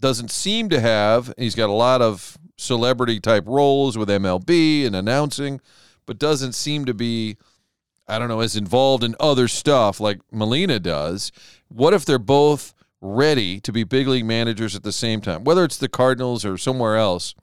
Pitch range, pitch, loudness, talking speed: 110-140 Hz, 120 Hz, -19 LUFS, 185 wpm